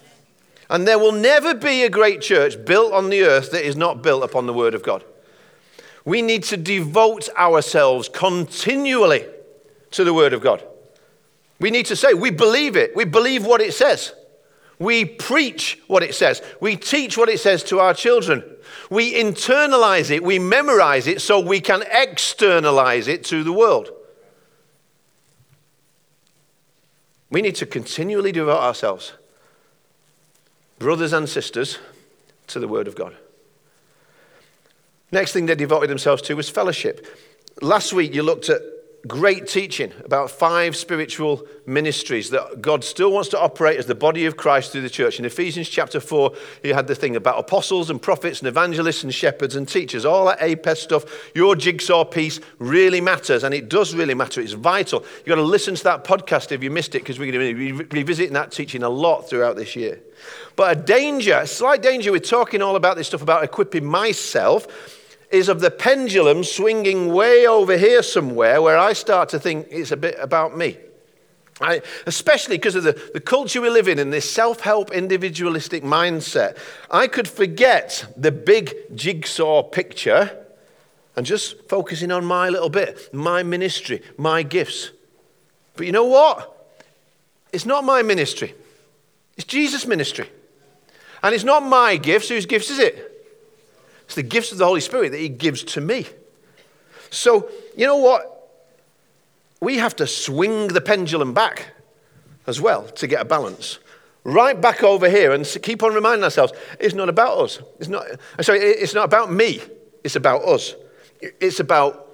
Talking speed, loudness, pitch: 170 wpm, -18 LUFS, 205 Hz